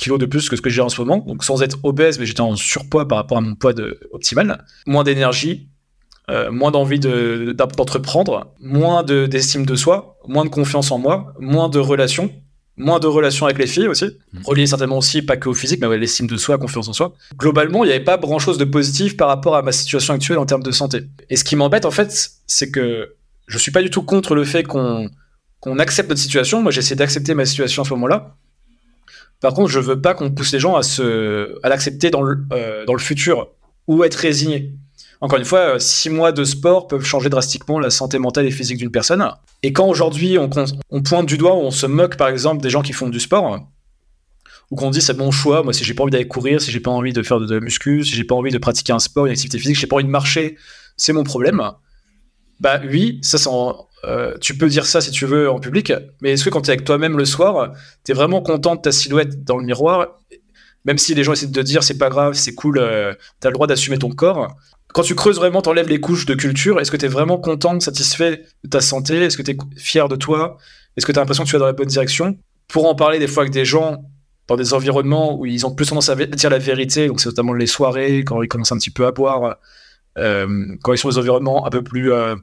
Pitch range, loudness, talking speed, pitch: 130-155 Hz, -16 LUFS, 260 wpm, 140 Hz